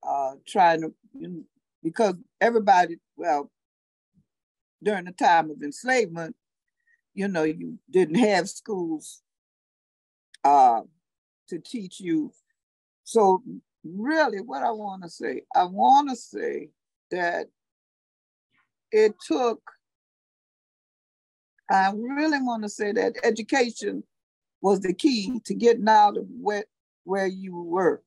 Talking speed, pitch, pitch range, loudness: 120 wpm, 225 Hz, 190-295 Hz, -24 LUFS